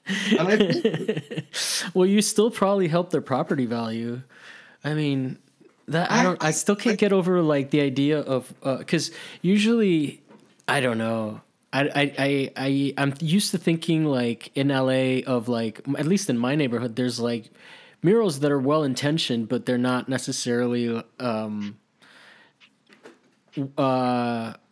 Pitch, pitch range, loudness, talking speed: 140 Hz, 125-175 Hz, -24 LUFS, 140 wpm